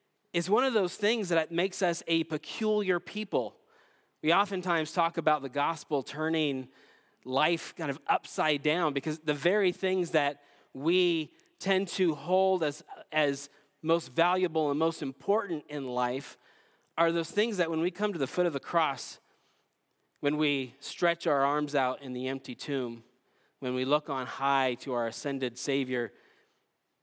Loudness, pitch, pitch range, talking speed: -30 LUFS, 155 Hz, 140-175 Hz, 160 wpm